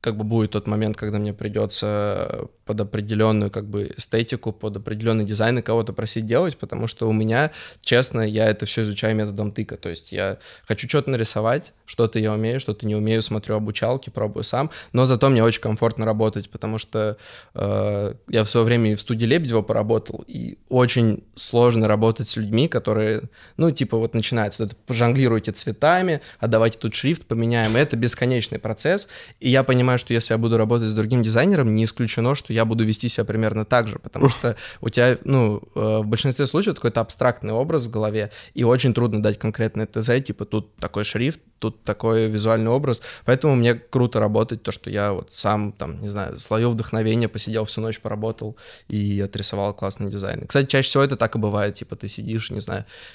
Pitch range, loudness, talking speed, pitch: 105-120 Hz, -22 LUFS, 190 wpm, 110 Hz